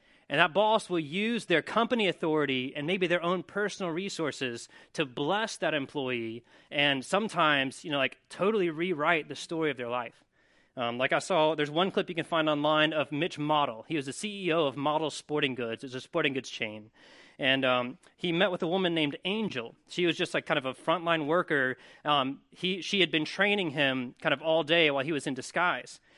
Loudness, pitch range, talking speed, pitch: -29 LUFS, 135-180 Hz, 210 wpm, 155 Hz